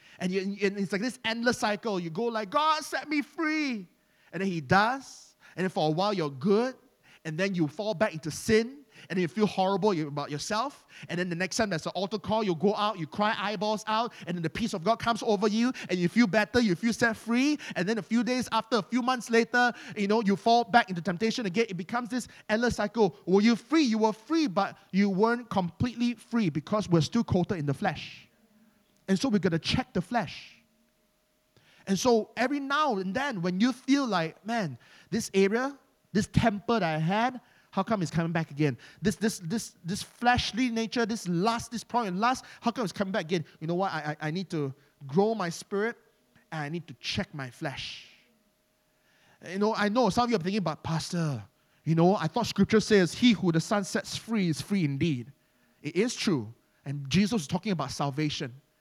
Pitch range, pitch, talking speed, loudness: 170-230 Hz, 205 Hz, 220 wpm, -28 LUFS